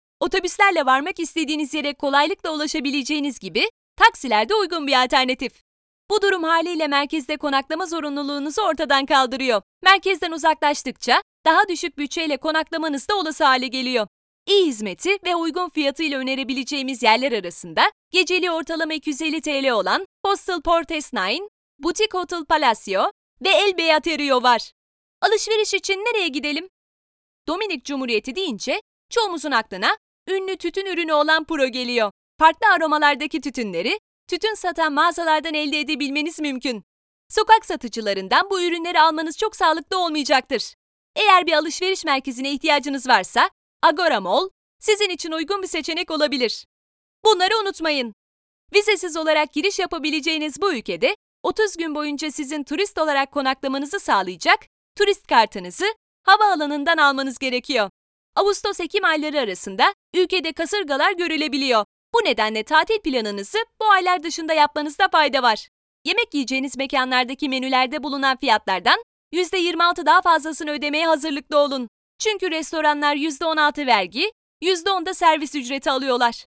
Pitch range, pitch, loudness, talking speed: 275-365 Hz, 315 Hz, -20 LUFS, 125 wpm